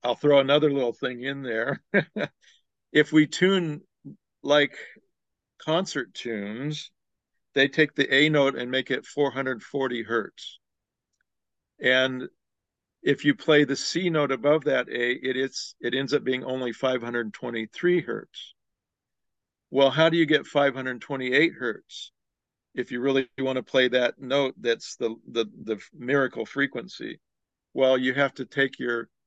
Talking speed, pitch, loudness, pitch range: 140 wpm, 135 Hz, -25 LUFS, 125-145 Hz